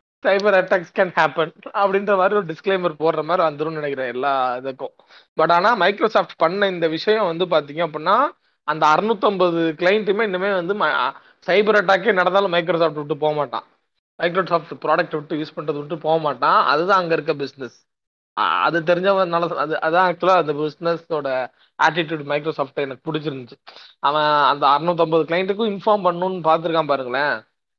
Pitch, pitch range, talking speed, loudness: 165 Hz, 155-190 Hz, 145 wpm, -19 LUFS